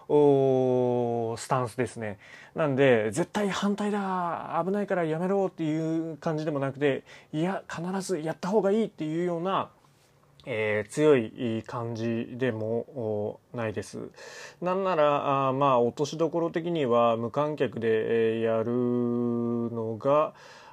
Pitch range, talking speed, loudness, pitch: 115-165 Hz, 255 characters per minute, -27 LUFS, 140 Hz